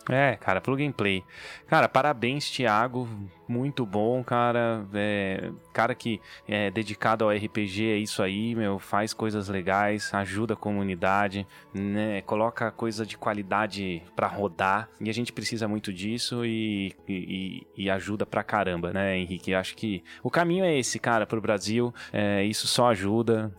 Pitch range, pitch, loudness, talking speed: 100-115 Hz, 105 Hz, -27 LUFS, 160 wpm